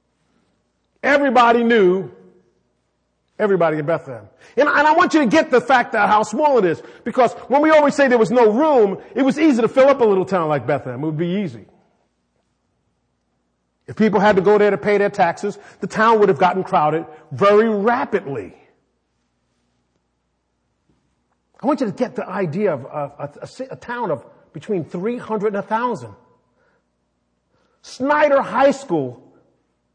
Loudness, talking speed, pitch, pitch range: -17 LUFS, 160 wpm, 200 Hz, 145-240 Hz